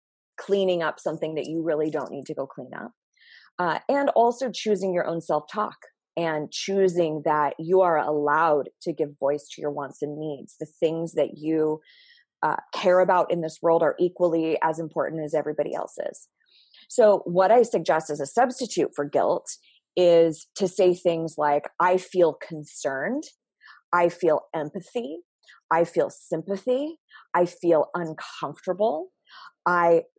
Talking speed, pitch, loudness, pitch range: 155 wpm, 170 Hz, -24 LUFS, 155-190 Hz